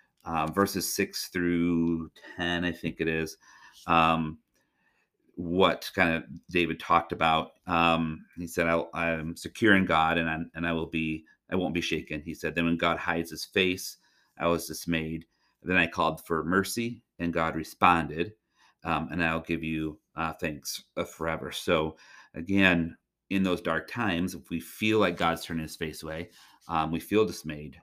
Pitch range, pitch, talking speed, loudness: 80-85 Hz, 85 Hz, 175 wpm, -28 LUFS